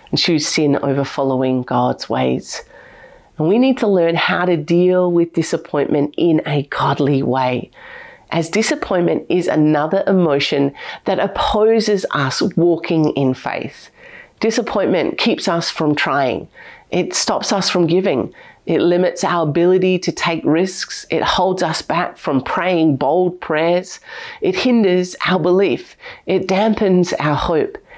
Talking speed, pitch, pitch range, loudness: 140 wpm, 175 Hz, 150-195 Hz, -17 LUFS